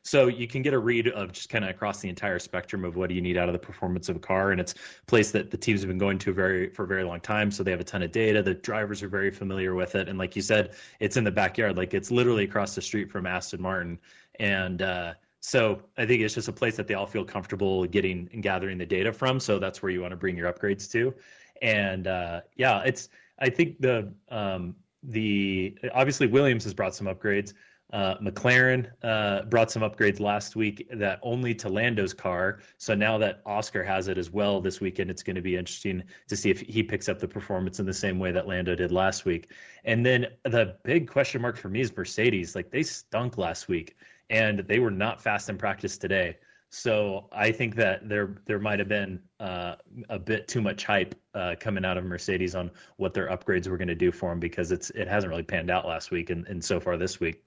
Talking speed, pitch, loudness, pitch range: 240 wpm, 100 Hz, -28 LUFS, 95-110 Hz